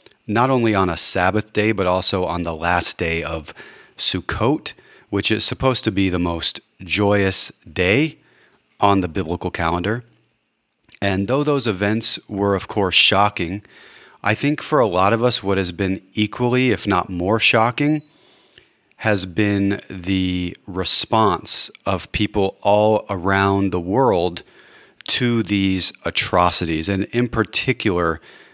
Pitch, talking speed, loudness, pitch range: 100 Hz, 140 wpm, -19 LUFS, 95-110 Hz